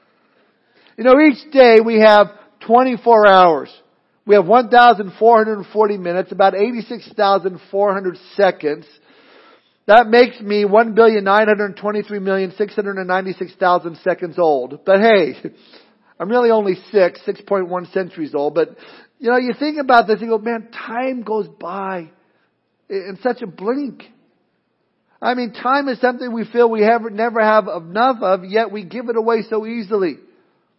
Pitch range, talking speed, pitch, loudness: 195-235 Hz, 135 wpm, 215 Hz, -15 LUFS